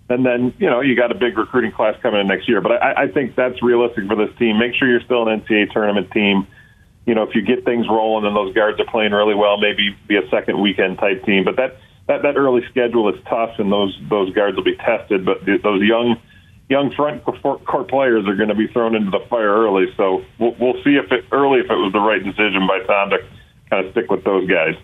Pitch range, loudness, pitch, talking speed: 105-120 Hz, -17 LUFS, 110 Hz, 255 wpm